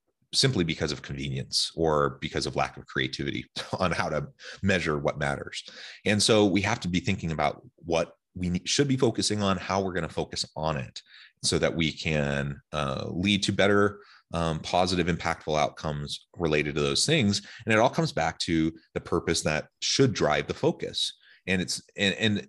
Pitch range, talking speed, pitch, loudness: 75-100 Hz, 185 wpm, 90 Hz, -27 LUFS